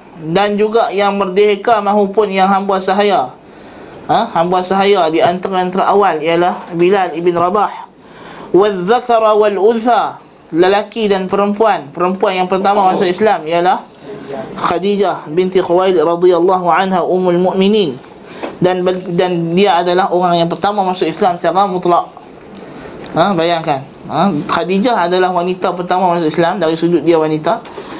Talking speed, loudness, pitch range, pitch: 135 wpm, -13 LUFS, 175-200 Hz, 185 Hz